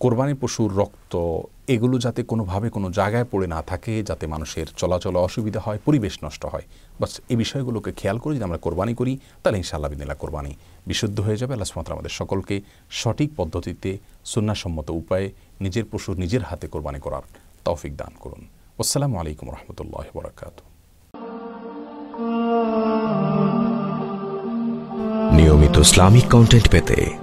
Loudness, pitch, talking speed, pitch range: -21 LUFS, 105 Hz, 125 wpm, 85-125 Hz